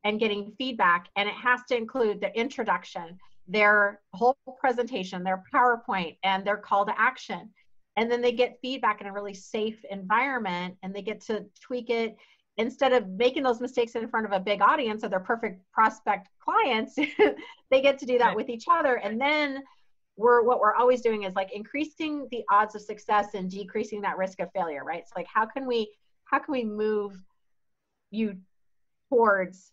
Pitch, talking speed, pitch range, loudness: 220 Hz, 185 wpm, 200-250 Hz, -26 LUFS